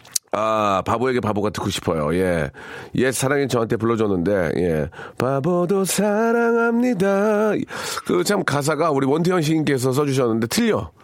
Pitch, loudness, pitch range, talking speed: 140 Hz, -20 LUFS, 115-190 Hz, 305 characters per minute